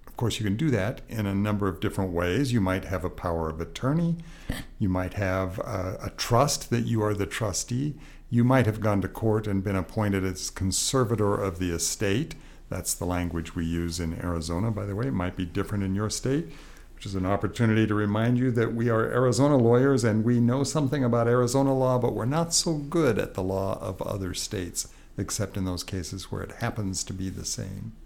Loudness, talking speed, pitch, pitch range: -27 LUFS, 220 wpm, 105 Hz, 95-125 Hz